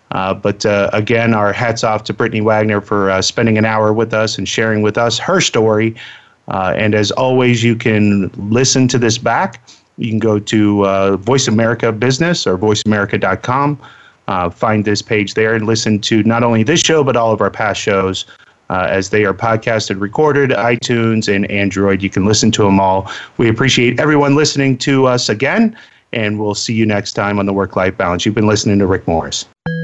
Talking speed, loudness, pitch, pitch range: 200 wpm, -14 LUFS, 110 Hz, 100-120 Hz